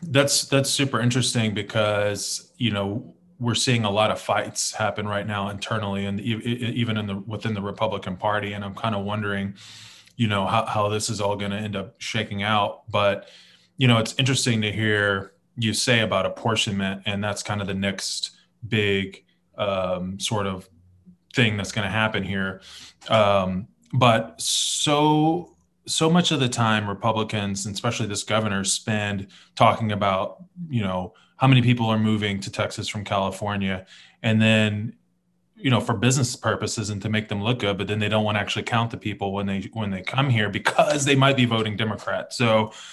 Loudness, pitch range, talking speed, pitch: -23 LUFS, 100-115 Hz, 185 wpm, 110 Hz